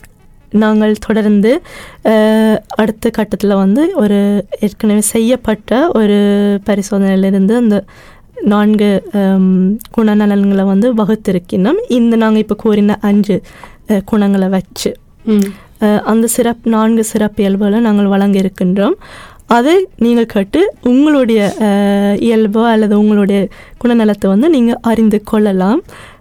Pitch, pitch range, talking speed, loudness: 210 Hz, 200-225 Hz, 95 wpm, -12 LUFS